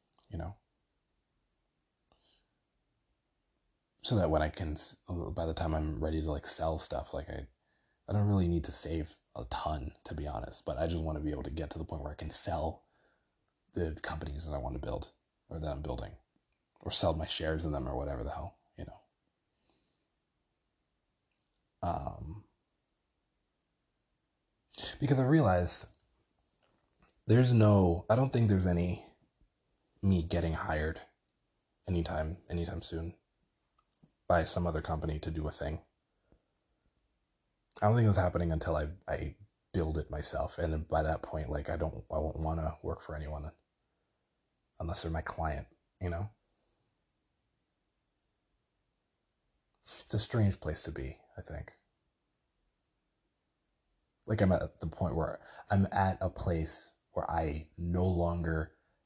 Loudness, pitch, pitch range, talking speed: -34 LUFS, 80 Hz, 75-90 Hz, 150 wpm